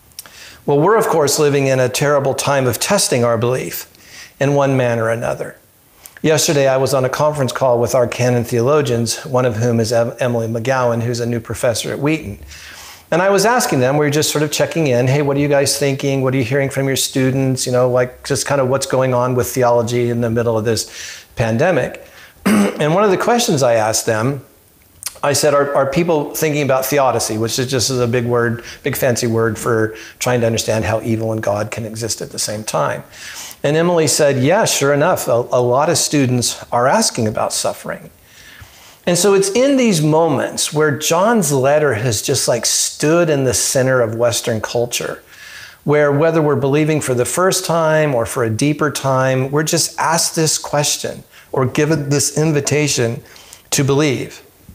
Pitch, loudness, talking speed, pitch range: 135 Hz, -16 LUFS, 200 wpm, 120-150 Hz